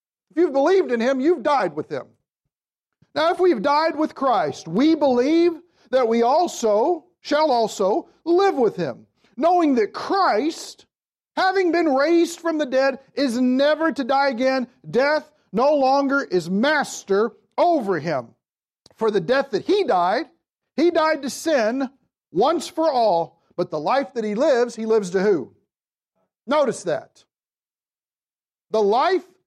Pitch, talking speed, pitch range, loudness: 280 Hz, 145 wpm, 235-330 Hz, -21 LUFS